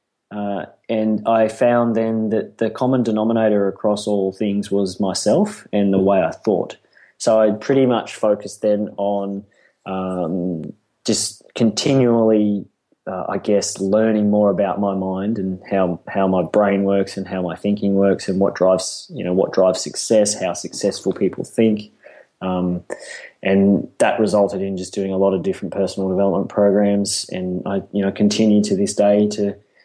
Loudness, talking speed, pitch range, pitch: -19 LUFS, 165 wpm, 95-110 Hz, 100 Hz